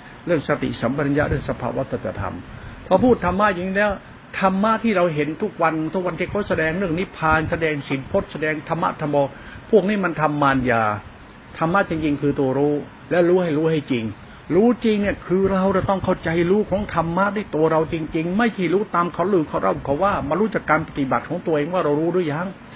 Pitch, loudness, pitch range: 165 Hz, -21 LUFS, 145-190 Hz